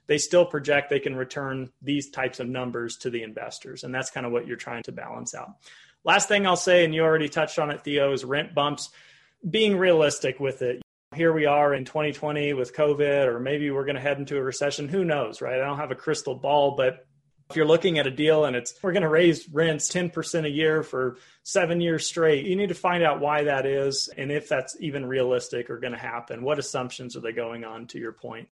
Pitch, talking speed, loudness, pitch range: 145 Hz, 240 wpm, -25 LUFS, 130-160 Hz